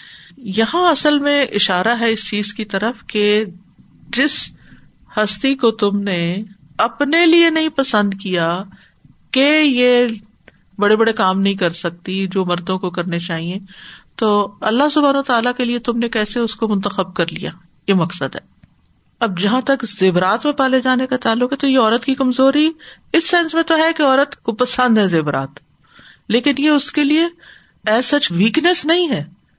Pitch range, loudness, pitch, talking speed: 195-275 Hz, -16 LUFS, 225 Hz, 175 wpm